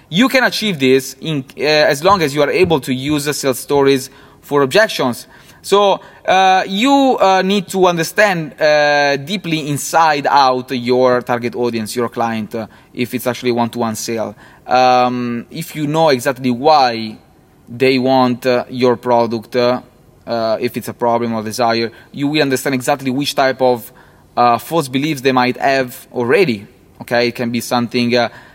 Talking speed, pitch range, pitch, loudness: 170 wpm, 120-150 Hz, 130 Hz, -15 LUFS